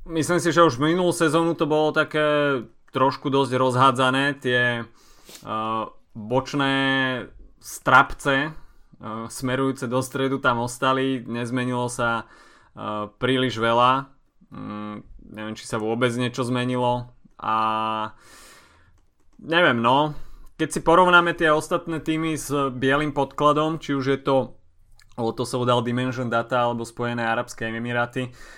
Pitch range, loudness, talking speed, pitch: 115-145 Hz, -22 LUFS, 120 wpm, 130 Hz